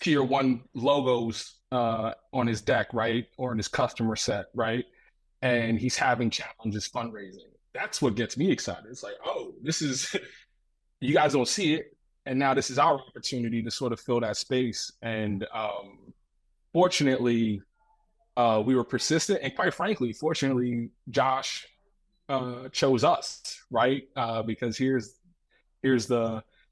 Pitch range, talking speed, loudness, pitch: 115-140 Hz, 150 wpm, -28 LUFS, 125 Hz